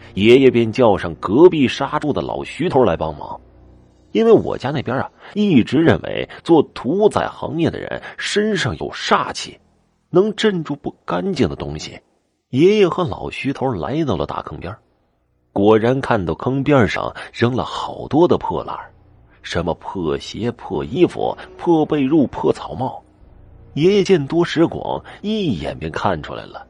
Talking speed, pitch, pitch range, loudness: 225 characters per minute, 140 Hz, 110-180 Hz, -18 LUFS